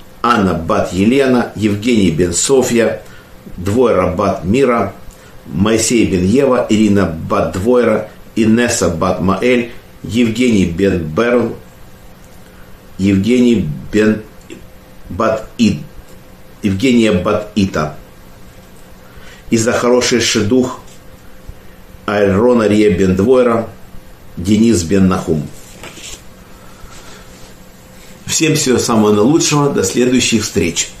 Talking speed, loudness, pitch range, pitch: 70 wpm, -13 LUFS, 95-120 Hz, 110 Hz